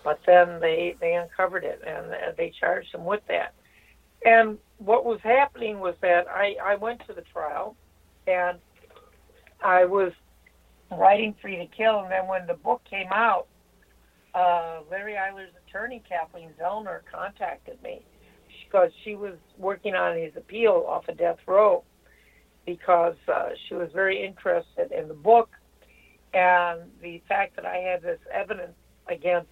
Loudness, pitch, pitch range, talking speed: -25 LUFS, 195 Hz, 175-230 Hz, 155 wpm